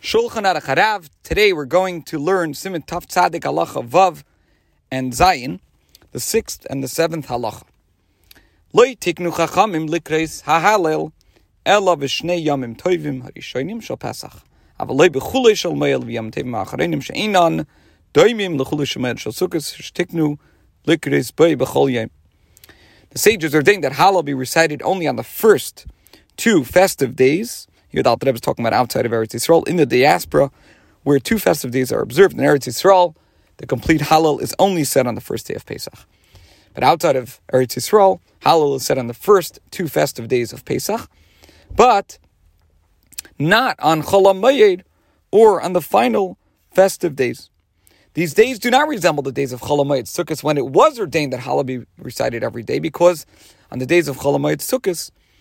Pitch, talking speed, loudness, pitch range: 145 Hz, 170 wpm, -17 LUFS, 115-175 Hz